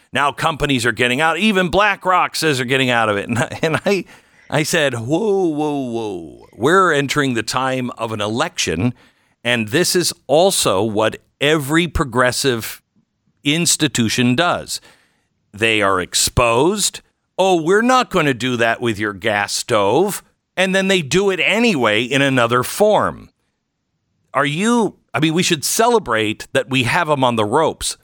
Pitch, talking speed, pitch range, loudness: 145 Hz, 160 wpm, 125-180 Hz, -16 LUFS